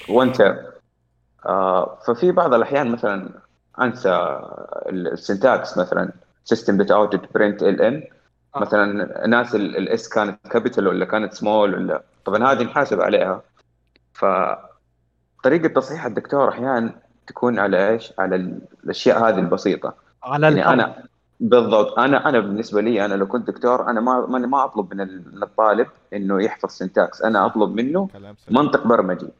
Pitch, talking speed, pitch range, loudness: 105 Hz, 130 wpm, 95-125 Hz, -19 LUFS